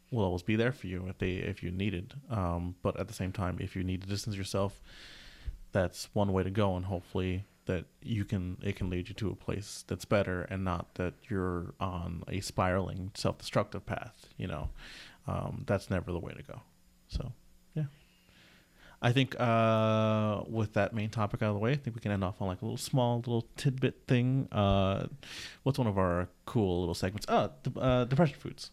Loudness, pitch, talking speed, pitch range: -33 LUFS, 100 Hz, 210 wpm, 95-115 Hz